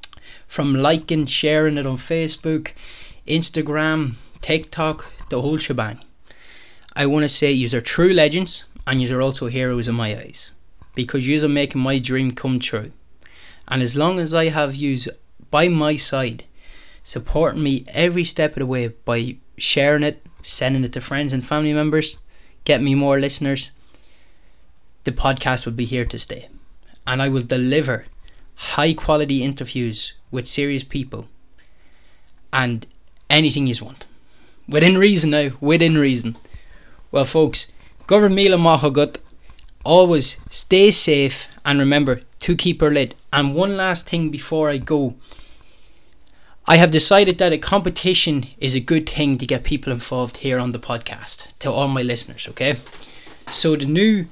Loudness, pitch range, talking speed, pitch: -18 LUFS, 125-155 Hz, 150 wpm, 140 Hz